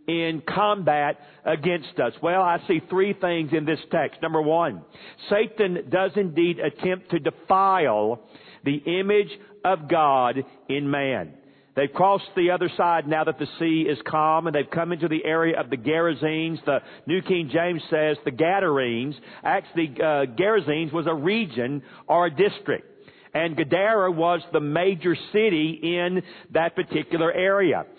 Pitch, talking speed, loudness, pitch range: 165 Hz, 155 wpm, -23 LUFS, 155-185 Hz